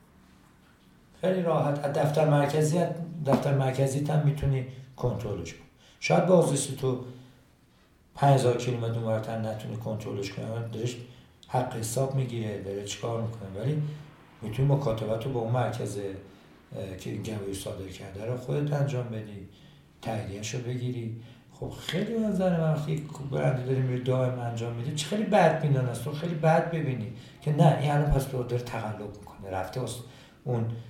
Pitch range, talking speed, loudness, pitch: 110-145 Hz, 150 wpm, -29 LUFS, 125 Hz